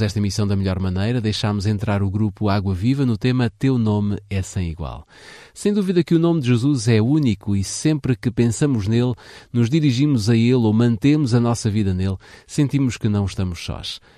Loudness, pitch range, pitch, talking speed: -20 LUFS, 100-130 Hz, 115 Hz, 200 wpm